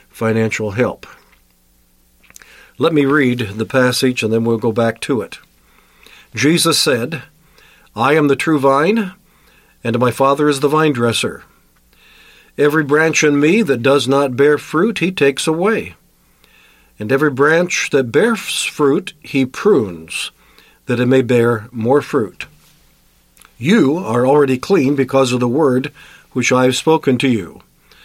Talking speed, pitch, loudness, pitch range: 145 wpm, 135 Hz, -15 LUFS, 115-150 Hz